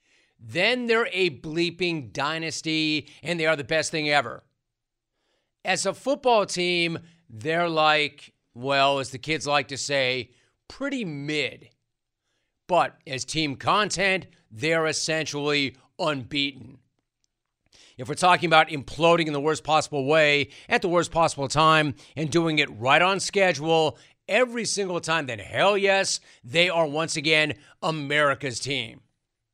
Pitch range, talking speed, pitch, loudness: 135-165 Hz, 135 wpm, 155 Hz, -23 LUFS